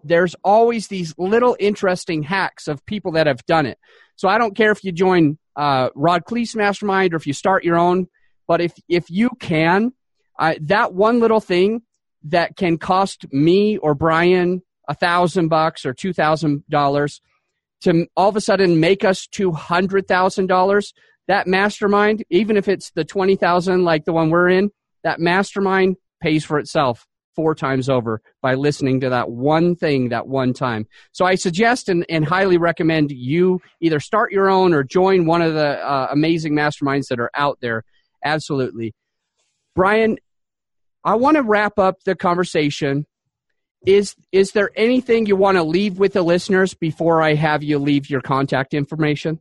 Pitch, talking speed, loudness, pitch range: 175 Hz, 170 wpm, -18 LUFS, 150-195 Hz